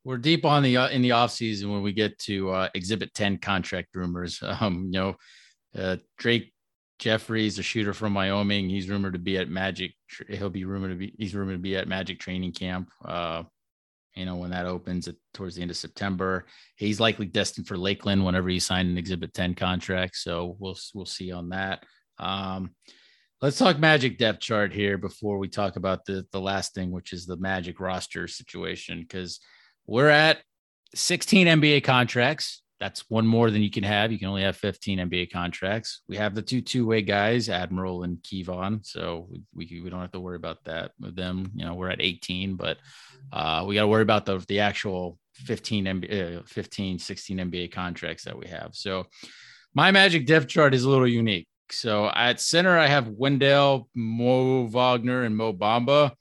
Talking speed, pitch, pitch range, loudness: 195 wpm, 100 Hz, 90-115 Hz, -25 LUFS